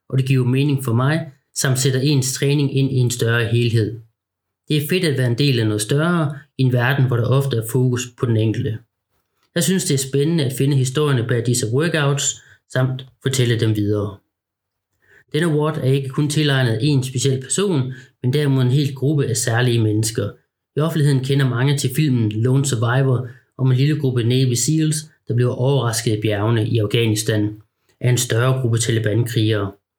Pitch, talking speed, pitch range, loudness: 130 Hz, 190 wpm, 115-140 Hz, -19 LUFS